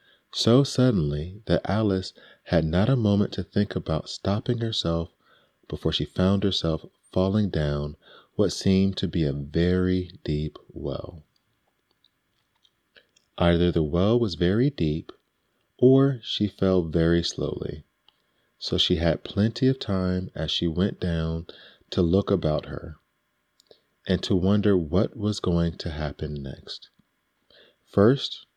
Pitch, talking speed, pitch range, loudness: 90 Hz, 130 wpm, 80-100 Hz, -25 LUFS